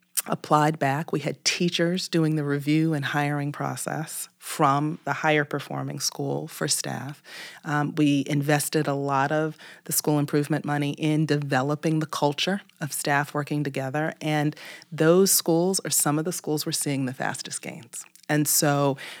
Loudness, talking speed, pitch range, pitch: -25 LUFS, 160 wpm, 145-160 Hz, 150 Hz